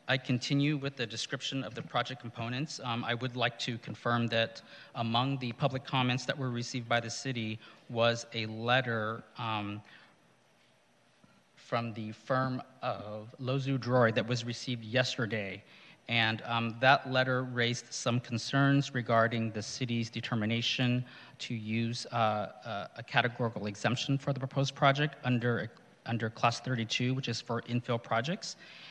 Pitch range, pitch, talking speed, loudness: 115-130 Hz, 120 Hz, 145 wpm, -32 LUFS